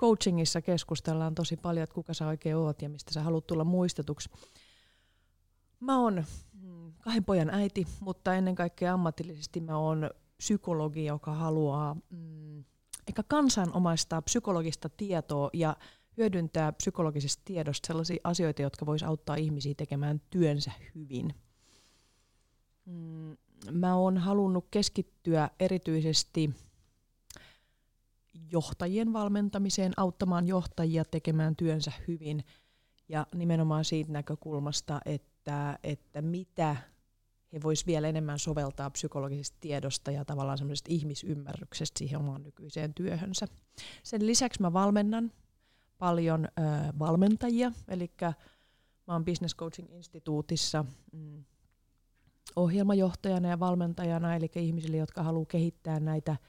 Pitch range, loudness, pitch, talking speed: 145-175 Hz, -32 LUFS, 160 Hz, 105 wpm